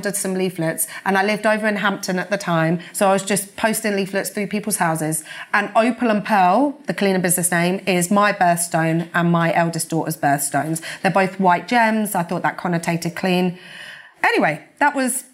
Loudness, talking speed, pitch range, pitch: -19 LUFS, 190 wpm, 170-205 Hz, 185 Hz